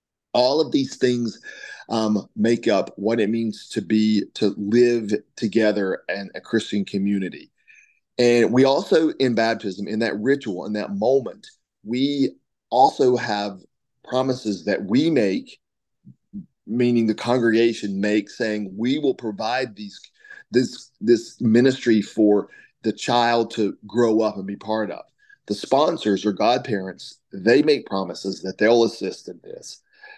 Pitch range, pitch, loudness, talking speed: 105-125 Hz, 115 Hz, -21 LUFS, 140 wpm